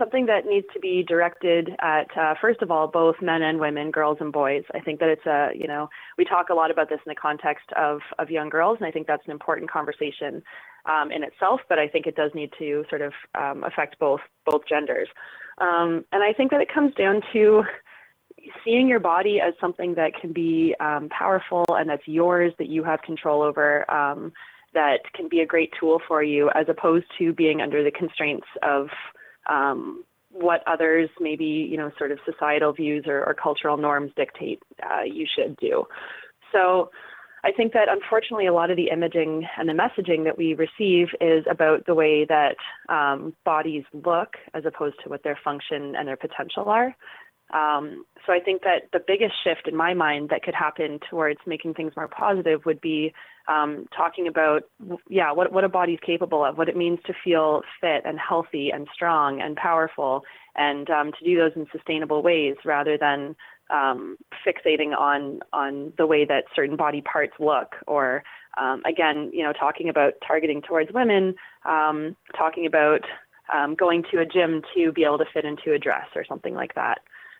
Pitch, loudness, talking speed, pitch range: 160 Hz, -23 LUFS, 195 wpm, 150-180 Hz